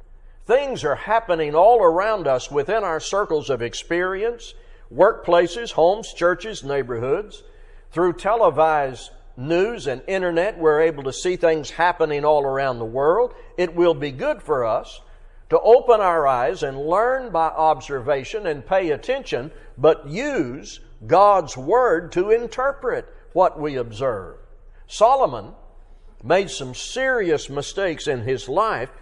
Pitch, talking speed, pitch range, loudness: 175 Hz, 130 wpm, 145-230 Hz, -20 LUFS